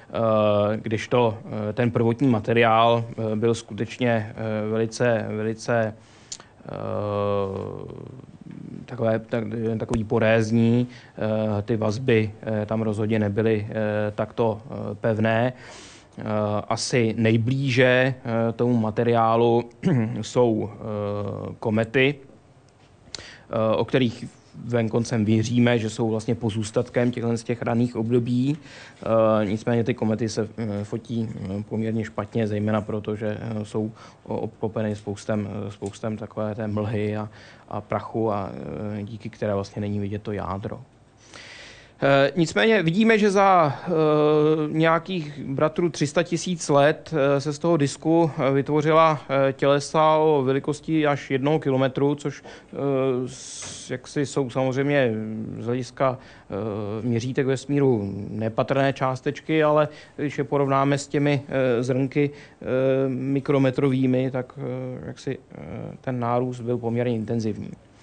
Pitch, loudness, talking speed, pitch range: 120 Hz, -23 LUFS, 105 wpm, 110-135 Hz